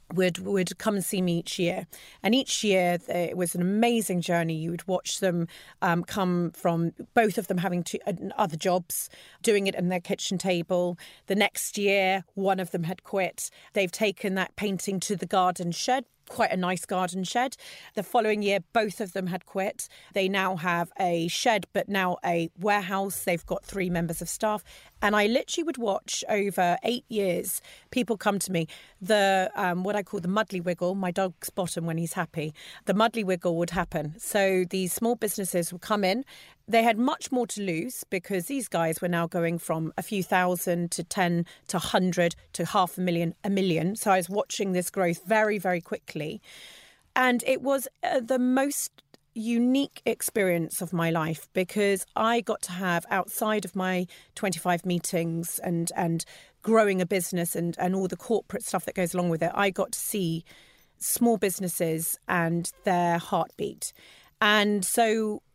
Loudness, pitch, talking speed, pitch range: -27 LUFS, 190 Hz, 185 wpm, 175-210 Hz